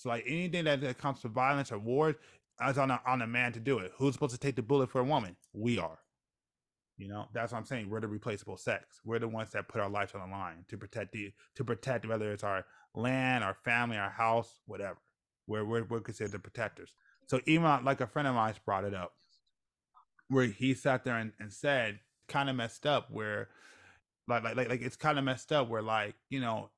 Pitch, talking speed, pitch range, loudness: 120 Hz, 230 wpm, 105-135 Hz, -34 LUFS